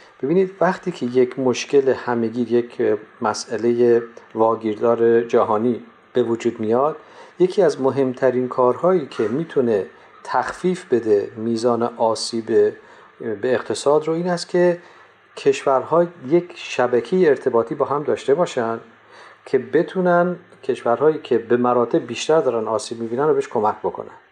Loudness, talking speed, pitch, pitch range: -20 LUFS, 125 wpm, 130 Hz, 120-180 Hz